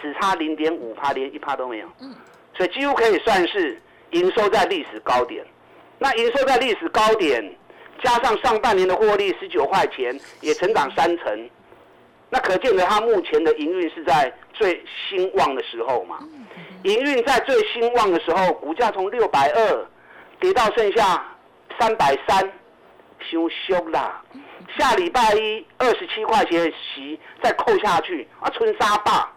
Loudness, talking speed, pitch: -20 LUFS, 235 characters per minute, 345 Hz